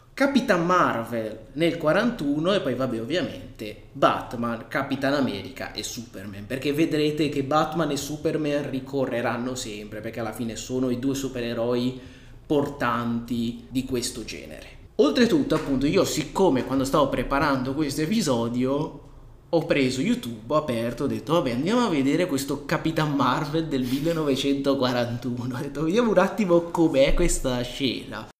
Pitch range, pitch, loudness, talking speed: 120-155 Hz, 135 Hz, -25 LUFS, 140 wpm